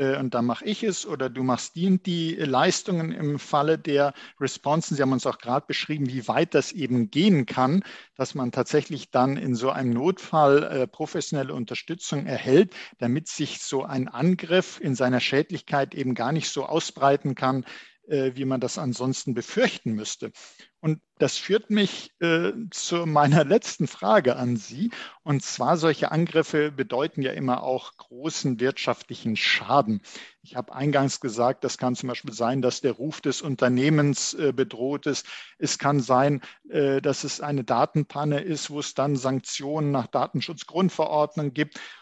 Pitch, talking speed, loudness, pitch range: 140 Hz, 160 wpm, -25 LUFS, 130-155 Hz